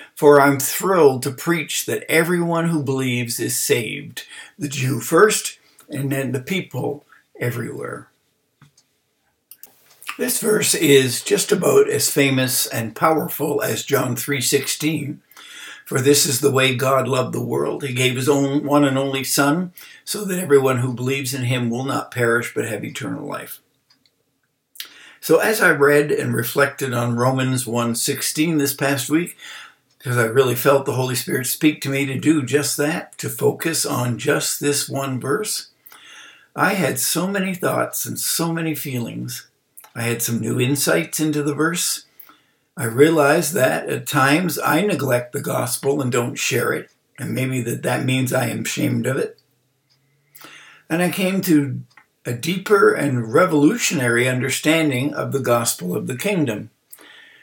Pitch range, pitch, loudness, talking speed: 130-150 Hz, 140 Hz, -19 LUFS, 155 wpm